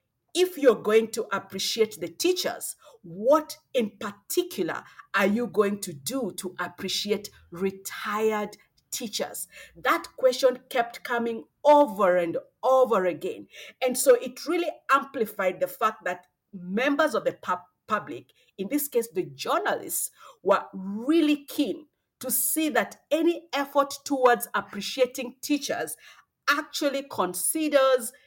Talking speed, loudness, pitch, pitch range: 120 wpm, -26 LUFS, 245 Hz, 200-290 Hz